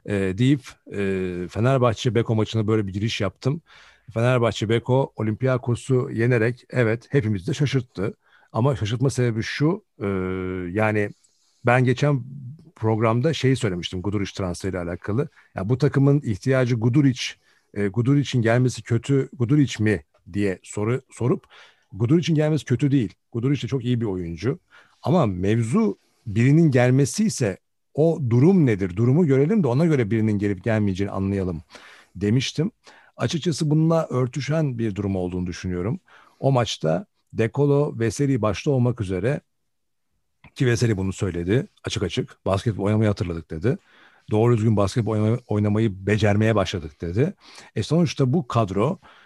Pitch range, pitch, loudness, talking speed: 105-135 Hz, 115 Hz, -23 LUFS, 135 wpm